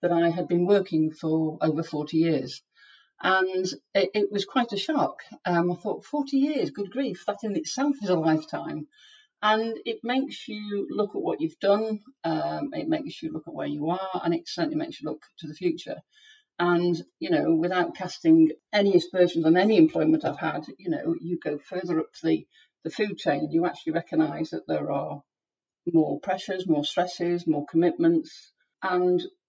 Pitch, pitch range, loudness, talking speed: 185 Hz, 165-240 Hz, -26 LUFS, 185 wpm